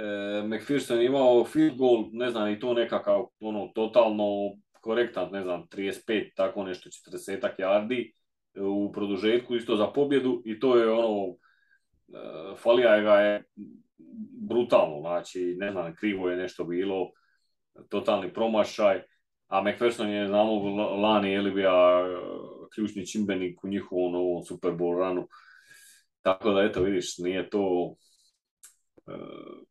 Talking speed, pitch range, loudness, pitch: 135 wpm, 95-120 Hz, -27 LUFS, 105 Hz